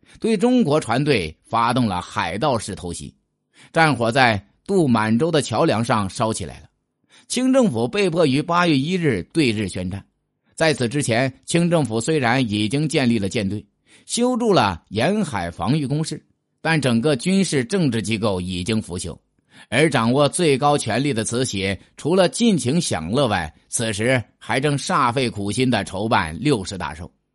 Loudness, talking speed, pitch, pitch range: -20 LUFS, 245 characters per minute, 125 Hz, 105-155 Hz